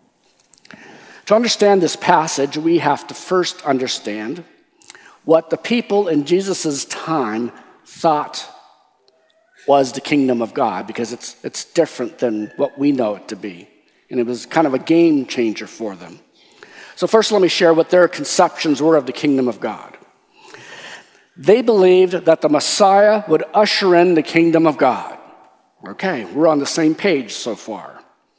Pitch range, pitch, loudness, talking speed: 135-185 Hz, 160 Hz, -16 LUFS, 160 wpm